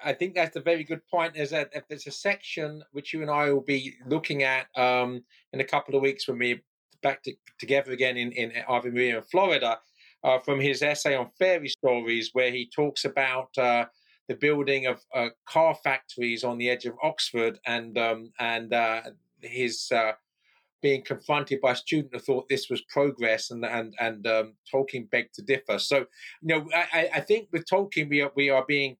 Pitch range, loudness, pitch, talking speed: 120-150 Hz, -27 LUFS, 135 Hz, 200 wpm